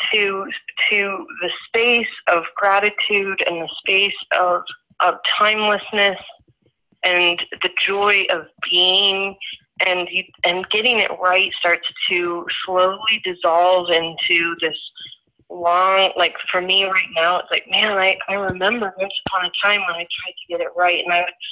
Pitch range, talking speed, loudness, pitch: 175-200 Hz, 150 wpm, -17 LUFS, 185 Hz